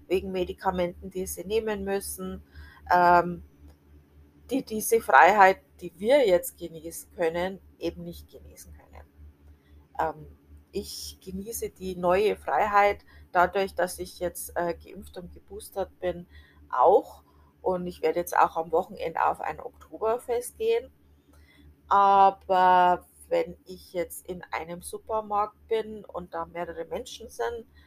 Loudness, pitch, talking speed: -26 LUFS, 175 Hz, 120 wpm